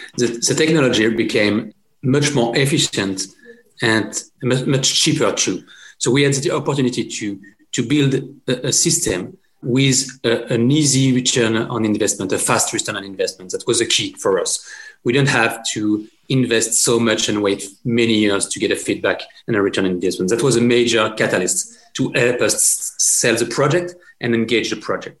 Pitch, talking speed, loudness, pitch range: 125 Hz, 180 wpm, -17 LUFS, 110-145 Hz